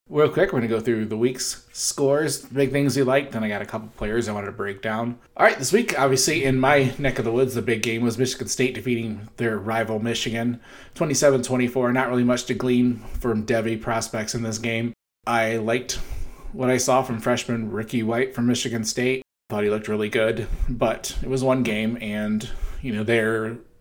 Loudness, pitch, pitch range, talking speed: -23 LUFS, 120 Hz, 110-130 Hz, 215 wpm